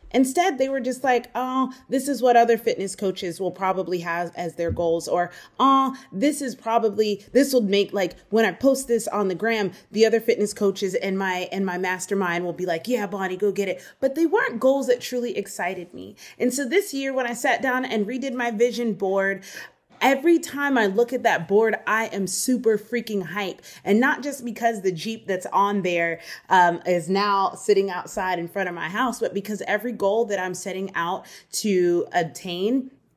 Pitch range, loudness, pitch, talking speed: 185-250 Hz, -23 LUFS, 210 Hz, 205 wpm